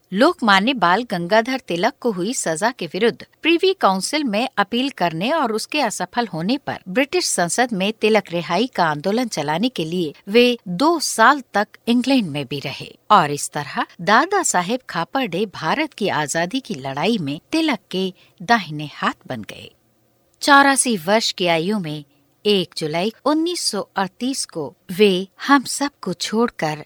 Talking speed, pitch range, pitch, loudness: 150 wpm, 175-250 Hz, 210 Hz, -19 LUFS